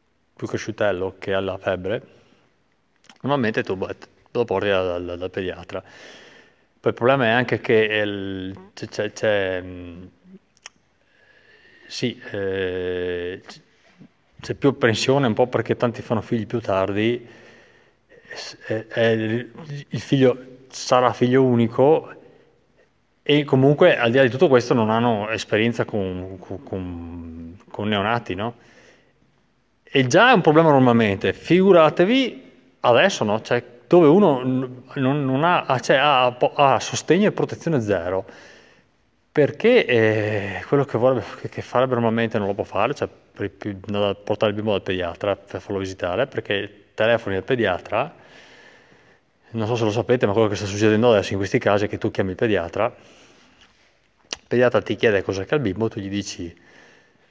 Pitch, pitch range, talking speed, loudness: 115 Hz, 100-130 Hz, 145 wpm, -20 LUFS